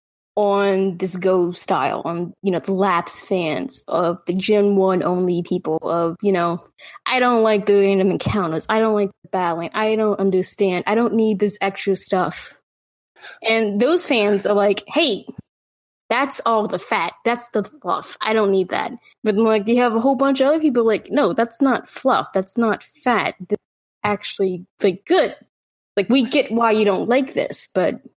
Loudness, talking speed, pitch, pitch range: -19 LUFS, 185 wpm, 205 Hz, 190-230 Hz